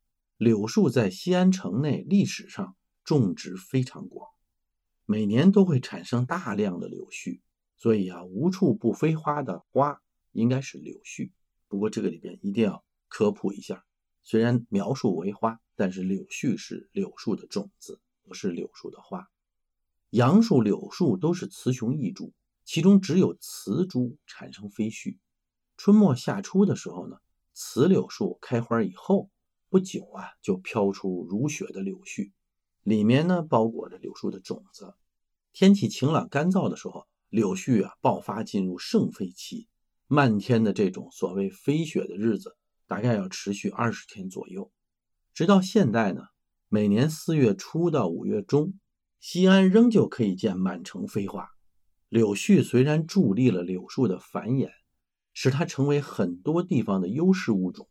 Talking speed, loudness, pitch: 230 characters per minute, -25 LUFS, 135 Hz